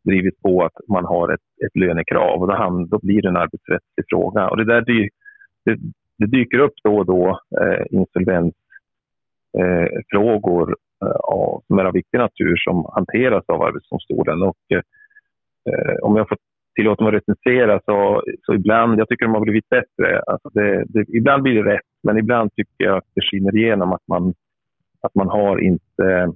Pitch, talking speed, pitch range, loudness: 110 Hz, 175 wpm, 100-130 Hz, -18 LUFS